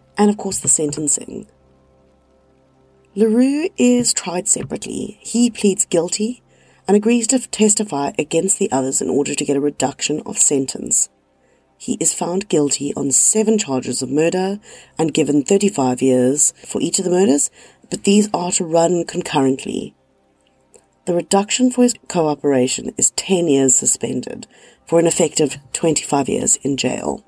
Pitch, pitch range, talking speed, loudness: 165 Hz, 135-200 Hz, 145 wpm, -17 LUFS